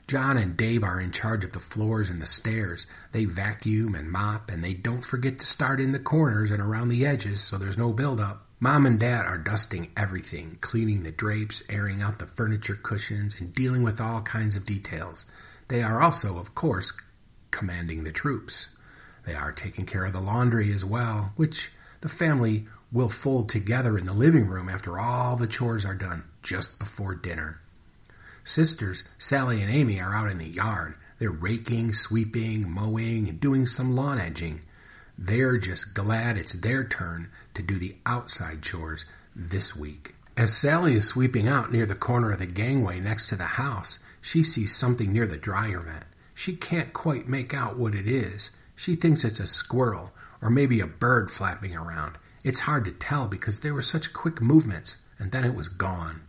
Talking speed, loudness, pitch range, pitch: 190 wpm, -26 LUFS, 95-120 Hz, 110 Hz